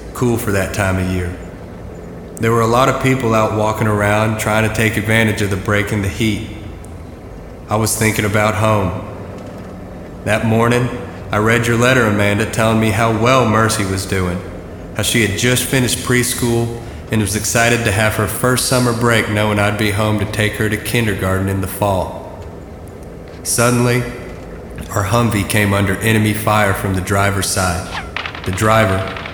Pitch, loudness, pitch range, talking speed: 105 Hz, -15 LUFS, 95-115 Hz, 170 wpm